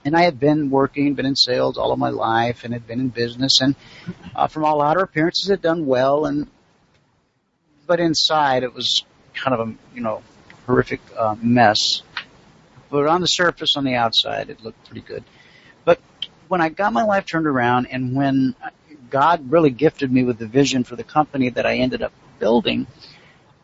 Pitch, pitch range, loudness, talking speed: 140 Hz, 125-160 Hz, -19 LUFS, 190 wpm